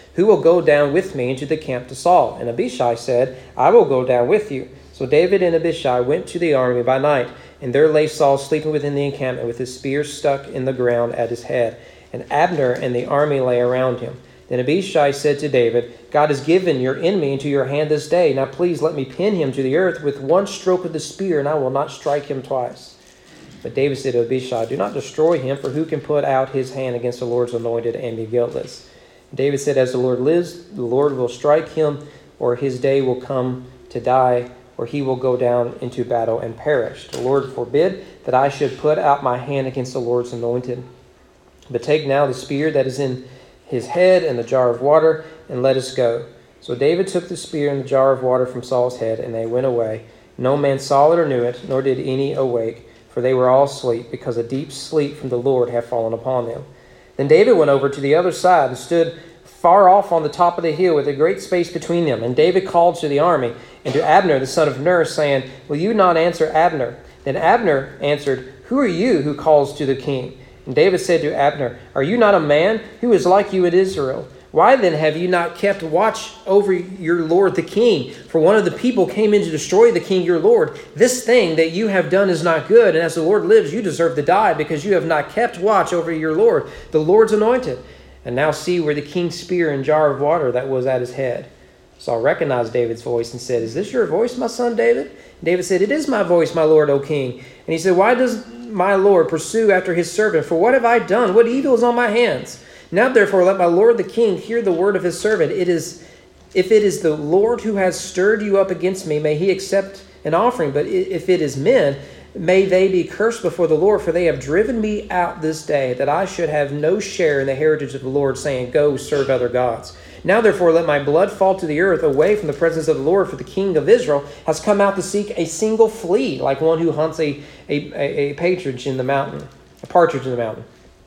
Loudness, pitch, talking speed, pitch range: -17 LUFS, 150 Hz, 240 wpm, 130-180 Hz